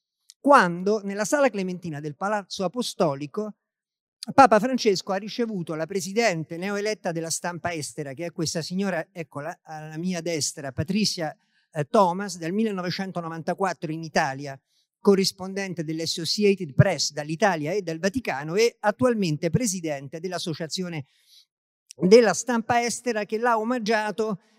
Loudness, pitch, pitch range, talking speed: -24 LUFS, 185 Hz, 165-210 Hz, 115 wpm